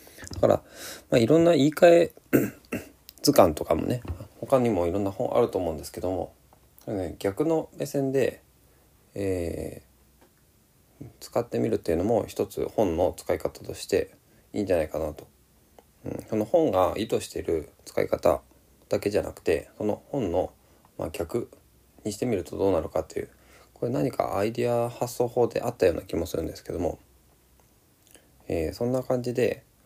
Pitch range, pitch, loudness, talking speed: 95-135 Hz, 120 Hz, -26 LUFS, 315 characters per minute